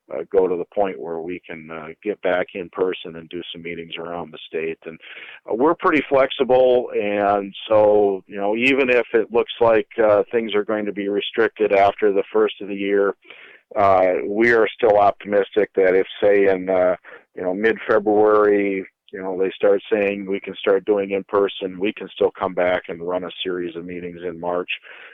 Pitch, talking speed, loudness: 100 Hz, 205 wpm, -20 LUFS